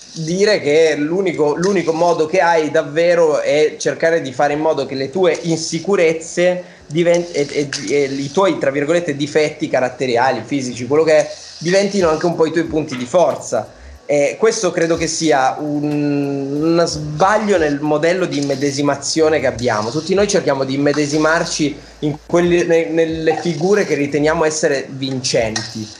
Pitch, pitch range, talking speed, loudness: 155 Hz, 145-170 Hz, 155 wpm, -16 LUFS